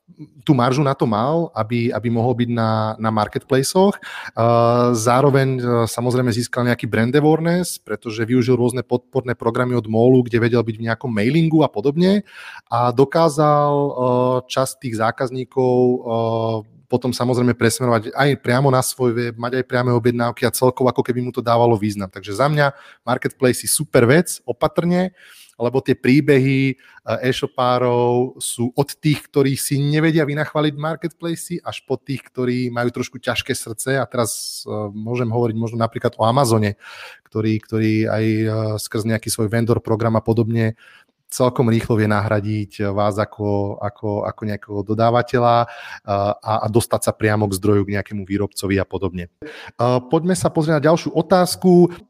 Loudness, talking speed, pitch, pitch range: -19 LUFS, 155 wpm, 120 Hz, 110-135 Hz